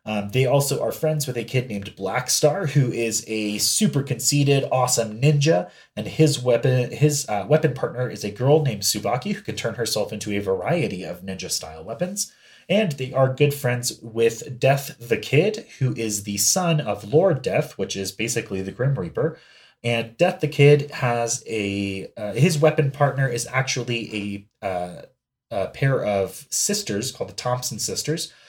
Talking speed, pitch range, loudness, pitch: 175 wpm, 110-150 Hz, -22 LUFS, 125 Hz